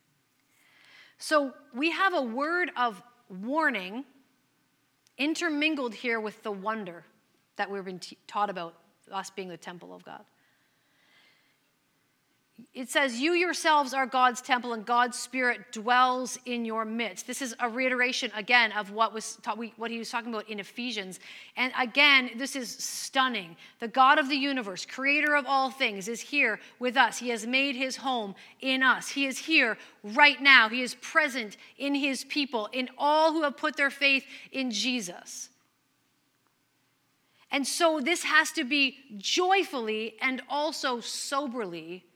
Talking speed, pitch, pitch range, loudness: 155 wpm, 250 Hz, 220-275 Hz, -27 LUFS